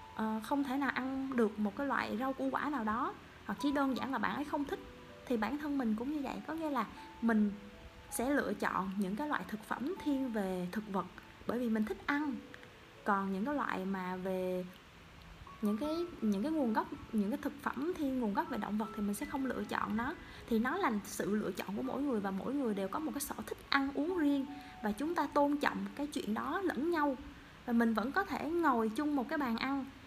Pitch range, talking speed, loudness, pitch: 215-290 Hz, 240 wpm, -36 LUFS, 260 Hz